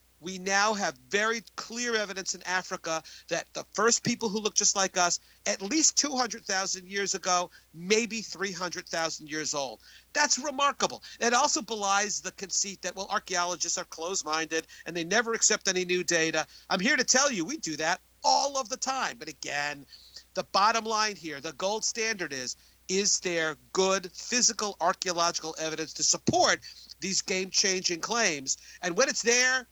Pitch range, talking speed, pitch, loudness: 170-225 Hz, 165 wpm, 190 Hz, -28 LUFS